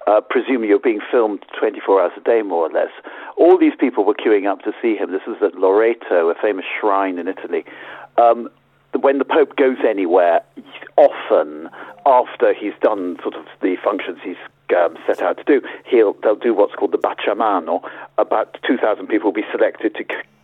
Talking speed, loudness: 190 wpm, -18 LUFS